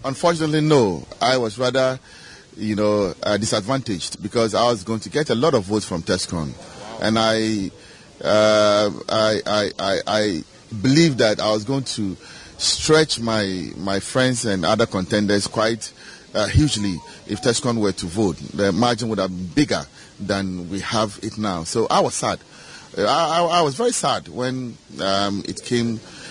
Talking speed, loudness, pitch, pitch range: 170 wpm, -20 LUFS, 110 Hz, 100-125 Hz